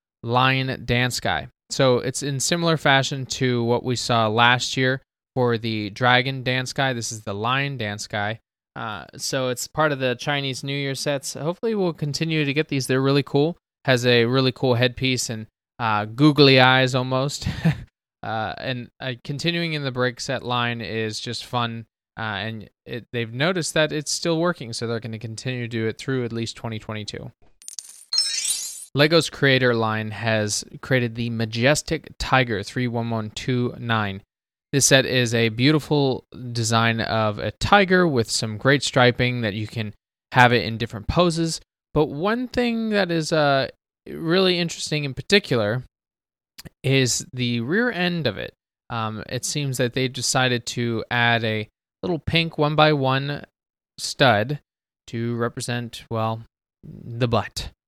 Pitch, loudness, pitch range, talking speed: 125 Hz, -22 LUFS, 115-145 Hz, 160 wpm